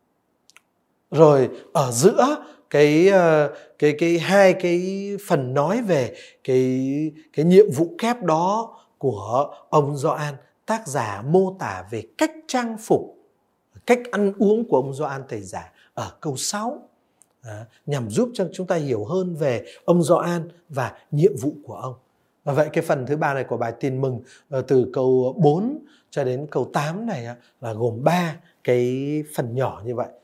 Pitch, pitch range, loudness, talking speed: 155 Hz, 130-190 Hz, -21 LUFS, 160 wpm